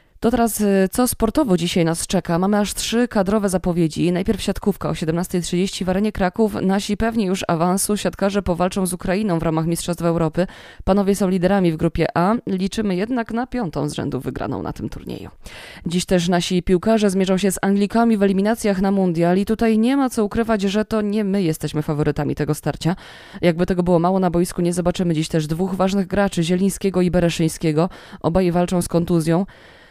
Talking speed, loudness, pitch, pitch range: 185 wpm, -20 LUFS, 185 Hz, 170-205 Hz